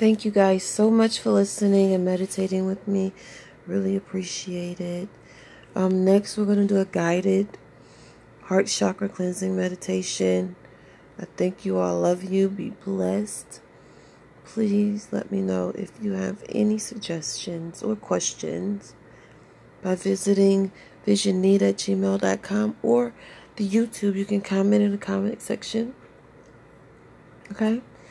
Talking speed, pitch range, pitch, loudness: 125 wpm, 185-205 Hz, 195 Hz, -24 LUFS